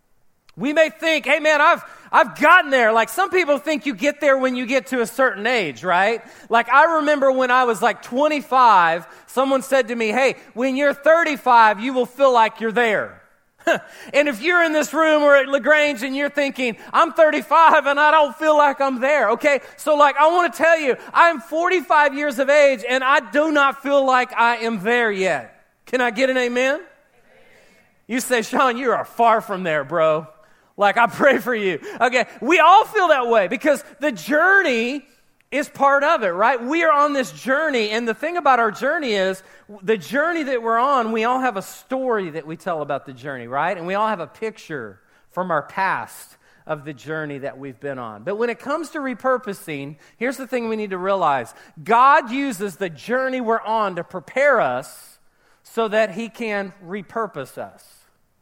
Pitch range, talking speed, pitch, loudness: 220-290 Hz, 200 wpm, 255 Hz, -18 LUFS